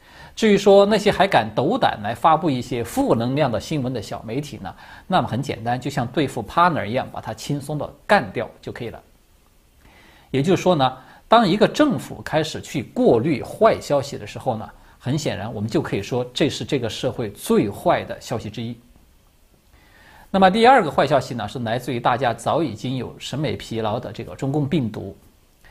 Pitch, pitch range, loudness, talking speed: 130 Hz, 110-155 Hz, -21 LUFS, 300 characters per minute